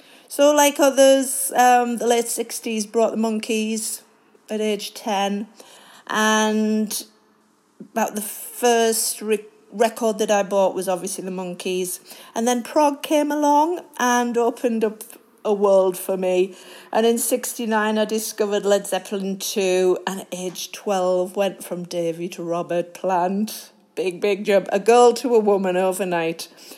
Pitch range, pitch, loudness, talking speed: 190-235 Hz, 215 Hz, -21 LUFS, 145 wpm